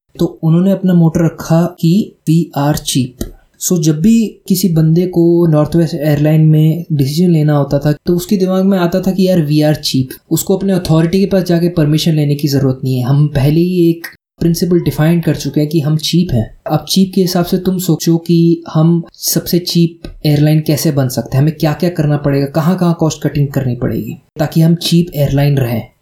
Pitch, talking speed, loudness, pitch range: 160 Hz, 210 wpm, -12 LUFS, 150-175 Hz